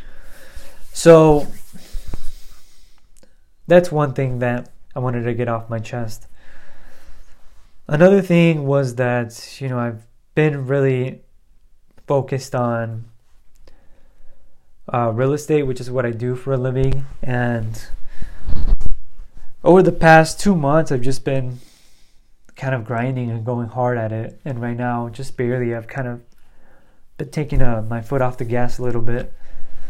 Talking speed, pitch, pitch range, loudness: 140 wpm, 125 Hz, 115-135 Hz, -19 LUFS